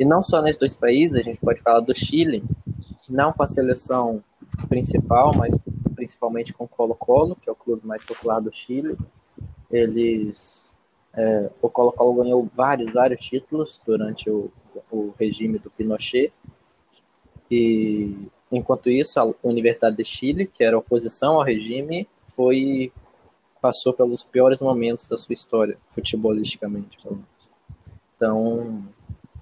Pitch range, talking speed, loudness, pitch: 110-130 Hz, 135 wpm, -22 LUFS, 115 Hz